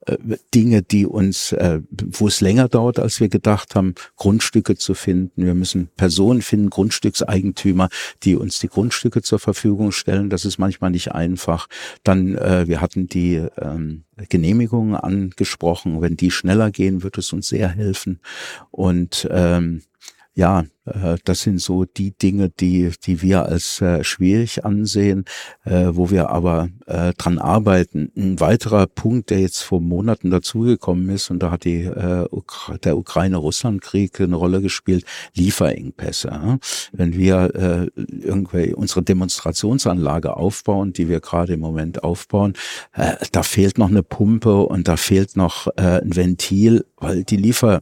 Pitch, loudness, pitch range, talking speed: 95 Hz, -18 LUFS, 90-105 Hz, 140 wpm